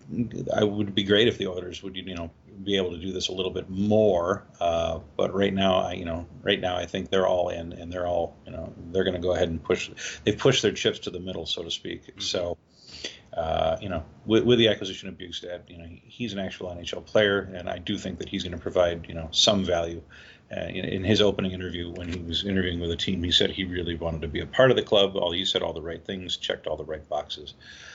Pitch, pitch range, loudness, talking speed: 90 Hz, 85-95 Hz, -26 LUFS, 260 wpm